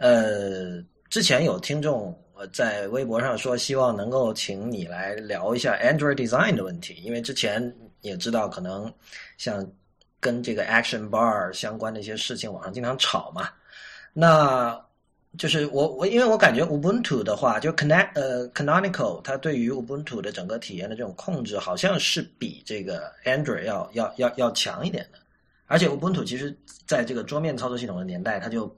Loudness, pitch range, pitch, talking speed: -25 LUFS, 120-160 Hz, 140 Hz, 360 characters per minute